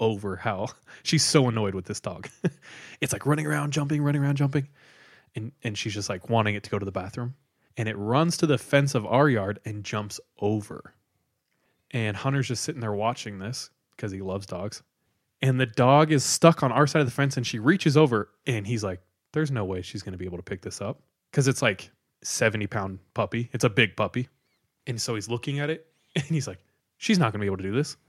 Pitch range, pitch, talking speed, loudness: 105-140 Hz, 120 Hz, 225 wpm, -26 LUFS